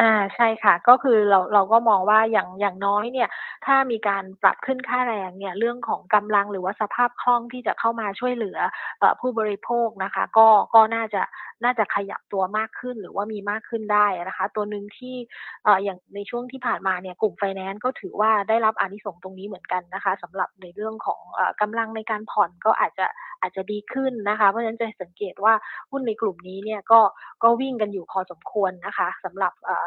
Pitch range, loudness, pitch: 195-230 Hz, -23 LUFS, 210 Hz